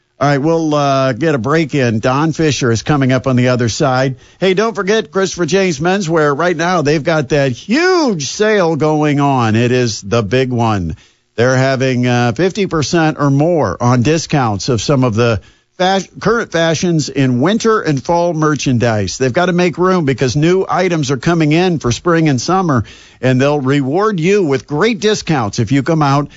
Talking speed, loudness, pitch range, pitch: 190 wpm, -13 LUFS, 130-175 Hz, 150 Hz